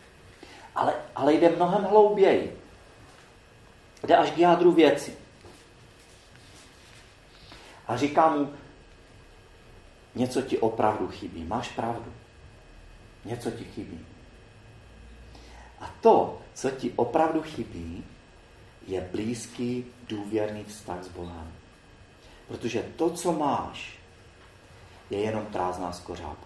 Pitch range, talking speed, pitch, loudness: 90-125 Hz, 95 wpm, 115 Hz, -26 LUFS